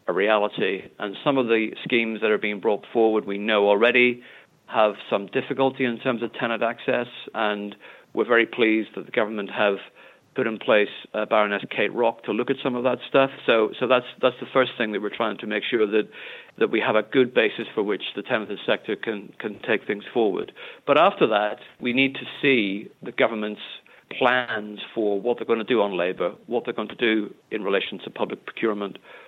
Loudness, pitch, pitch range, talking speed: -23 LUFS, 115 Hz, 105-135 Hz, 210 wpm